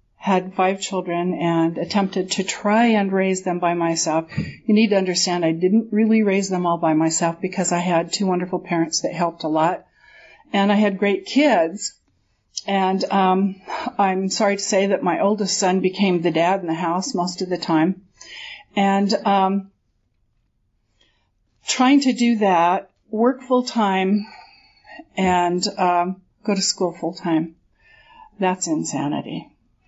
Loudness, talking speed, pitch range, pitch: -20 LUFS, 155 wpm, 170-200 Hz, 185 Hz